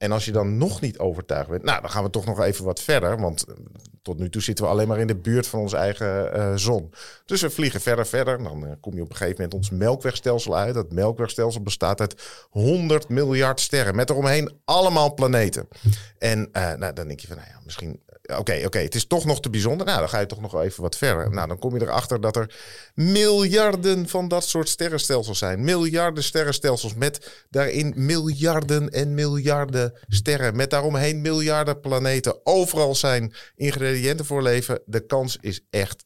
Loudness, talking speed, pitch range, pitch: -23 LUFS, 205 wpm, 105-145 Hz, 125 Hz